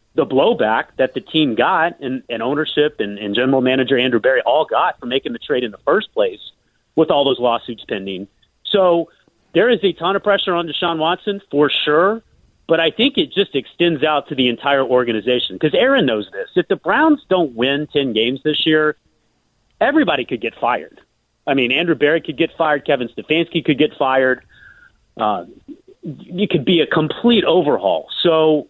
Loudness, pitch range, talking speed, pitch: -17 LUFS, 130-180 Hz, 190 wpm, 155 Hz